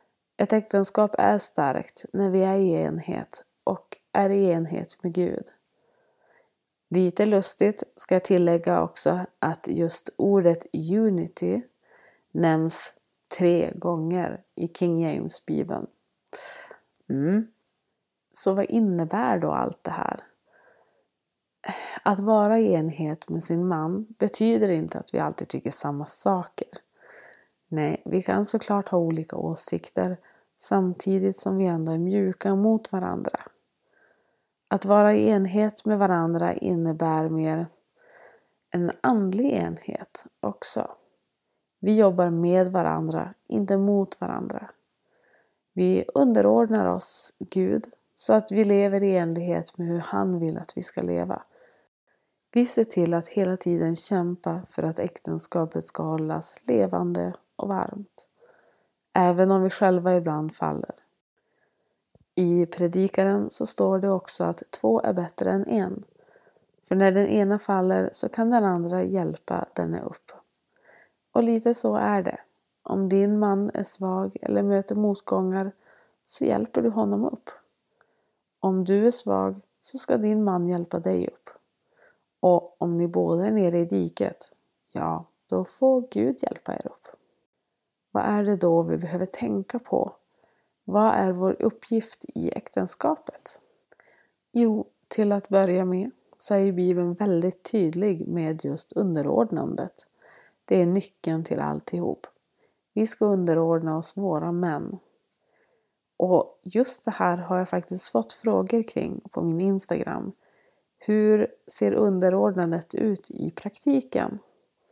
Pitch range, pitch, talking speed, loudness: 170-210 Hz, 185 Hz, 135 wpm, -25 LUFS